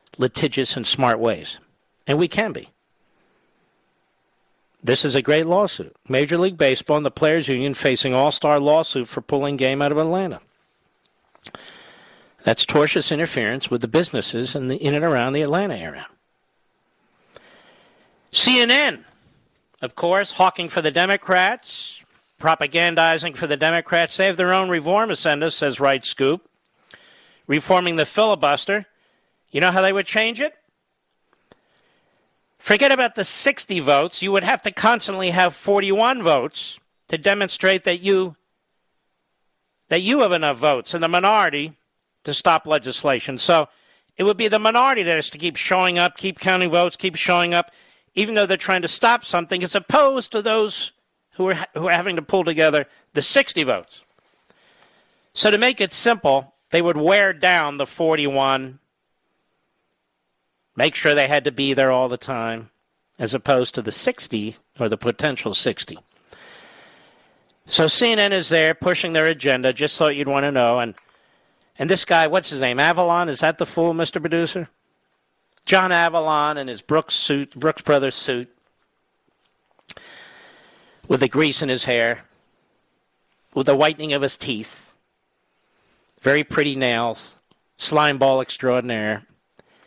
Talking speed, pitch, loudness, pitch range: 150 wpm, 160 Hz, -19 LUFS, 140-185 Hz